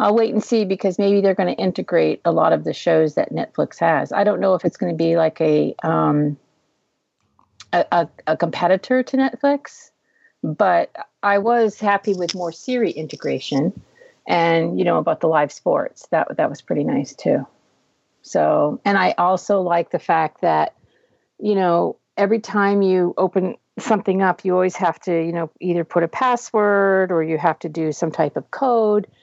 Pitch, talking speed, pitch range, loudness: 190 Hz, 185 wpm, 170-210 Hz, -19 LUFS